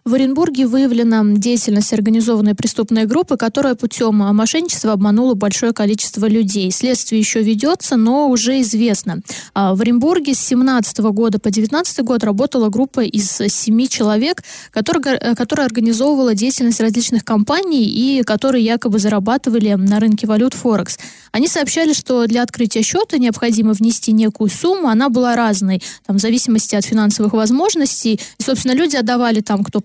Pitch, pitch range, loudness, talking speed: 230 Hz, 215-255 Hz, -15 LUFS, 145 wpm